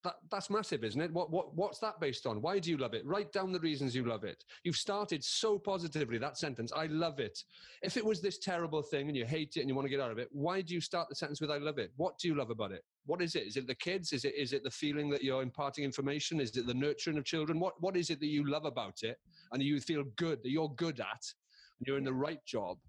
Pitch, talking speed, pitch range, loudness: 155 Hz, 295 wpm, 140-175 Hz, -37 LUFS